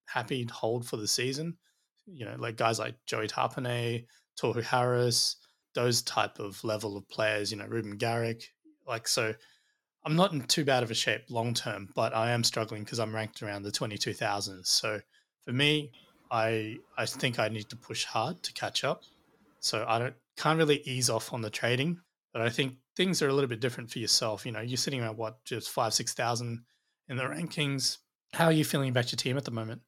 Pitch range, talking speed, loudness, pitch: 110-135 Hz, 215 wpm, -31 LUFS, 120 Hz